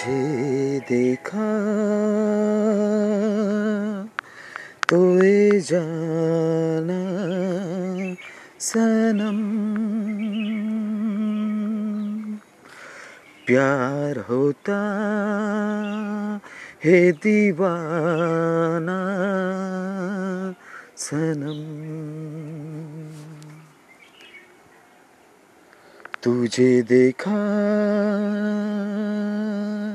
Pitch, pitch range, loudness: 200 Hz, 160-210 Hz, -22 LUFS